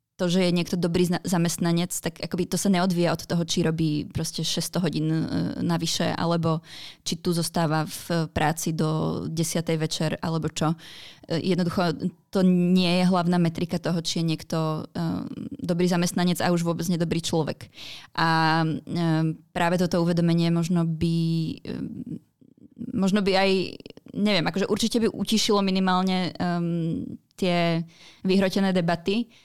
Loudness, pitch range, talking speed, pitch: -25 LUFS, 165-185 Hz, 130 wpm, 170 Hz